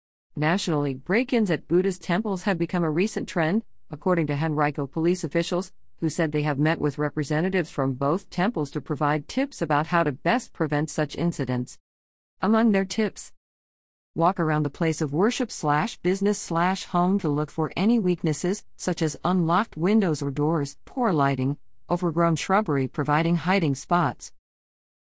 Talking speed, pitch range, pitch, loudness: 150 wpm, 150-185 Hz, 165 Hz, -25 LUFS